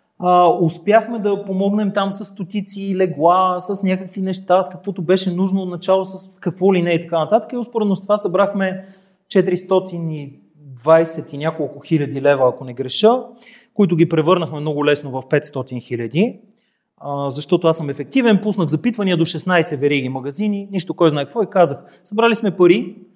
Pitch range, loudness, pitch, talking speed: 160-200 Hz, -18 LUFS, 185 Hz, 165 wpm